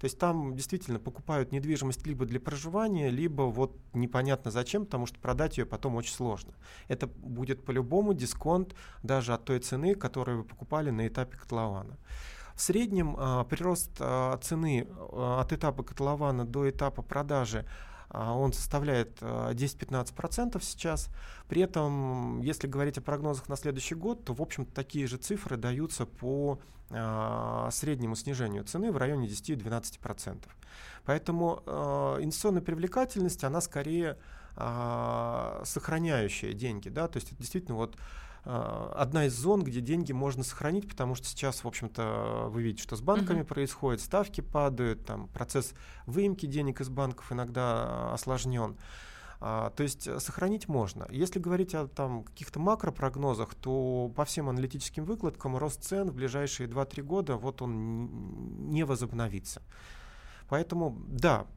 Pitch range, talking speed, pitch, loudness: 120-155 Hz, 135 wpm, 135 Hz, -33 LUFS